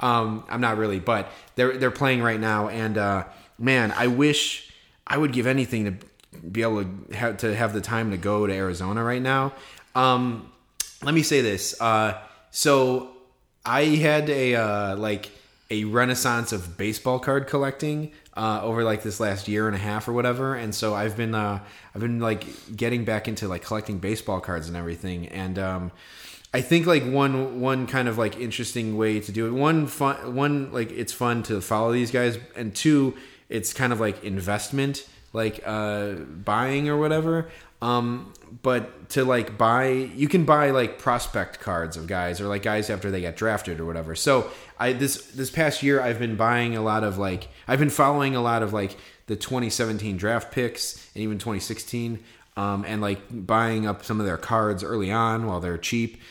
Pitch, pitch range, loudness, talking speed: 115 Hz, 105-130 Hz, -25 LUFS, 190 wpm